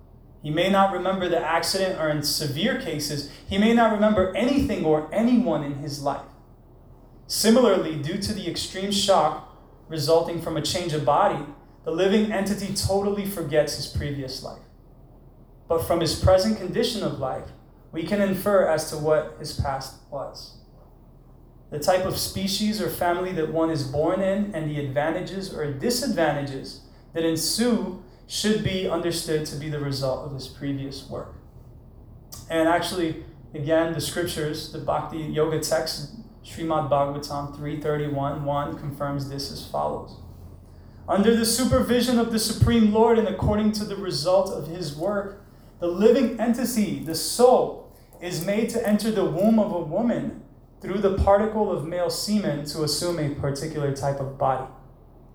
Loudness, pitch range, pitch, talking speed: -24 LUFS, 145-195 Hz, 165 Hz, 155 wpm